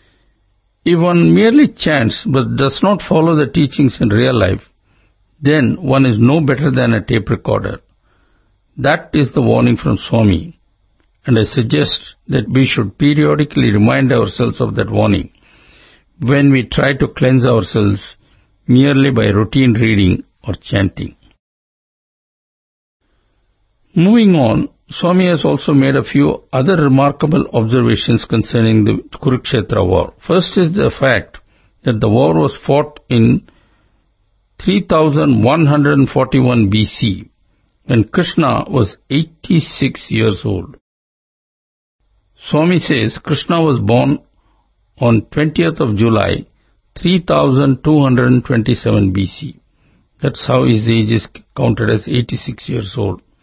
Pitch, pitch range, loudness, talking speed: 125 Hz, 110-150 Hz, -13 LUFS, 120 wpm